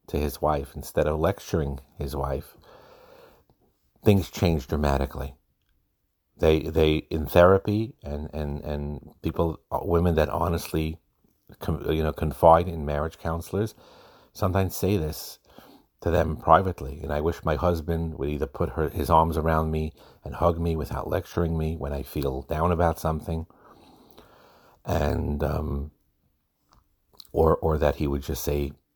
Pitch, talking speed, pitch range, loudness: 80 Hz, 145 wpm, 75-85 Hz, -26 LUFS